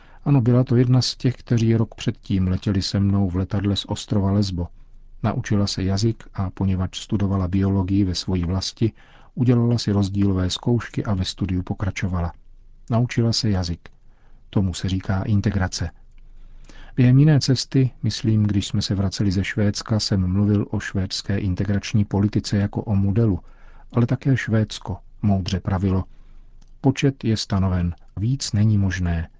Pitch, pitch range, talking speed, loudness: 100 Hz, 95-115 Hz, 145 wpm, -22 LUFS